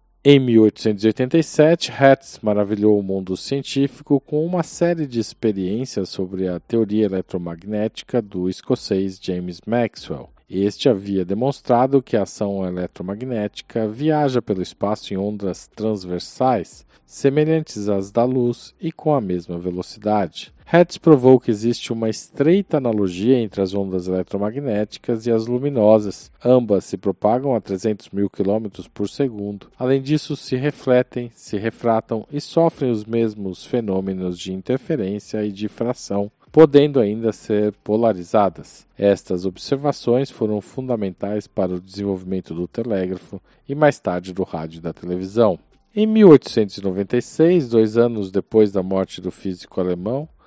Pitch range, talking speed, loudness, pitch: 95-130 Hz, 130 wpm, -20 LUFS, 110 Hz